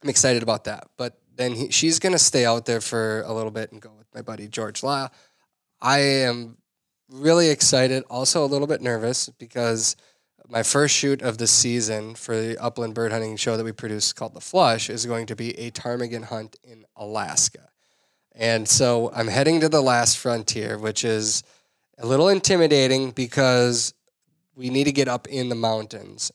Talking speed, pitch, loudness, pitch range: 185 wpm, 120 Hz, -21 LUFS, 115-135 Hz